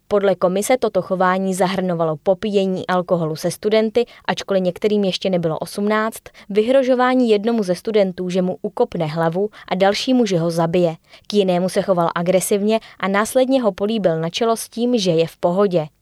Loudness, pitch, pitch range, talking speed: -19 LUFS, 190 Hz, 180-215 Hz, 165 wpm